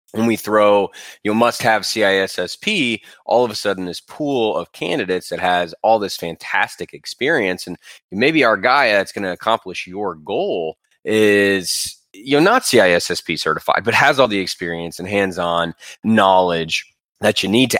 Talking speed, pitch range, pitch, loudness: 170 wpm, 90-110 Hz, 100 Hz, -17 LUFS